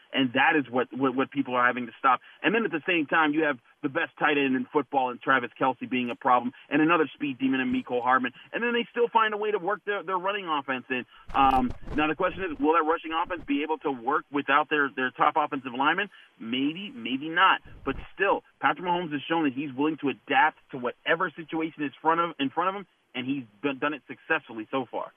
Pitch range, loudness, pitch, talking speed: 130-185 Hz, -27 LUFS, 150 Hz, 245 wpm